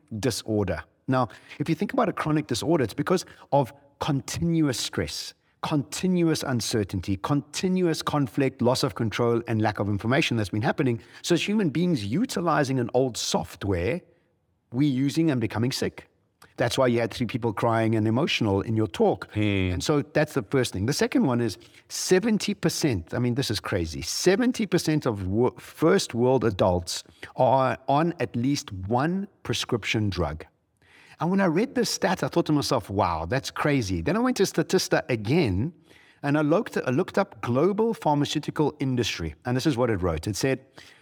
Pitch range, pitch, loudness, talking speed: 110-160 Hz, 135 Hz, -25 LUFS, 170 wpm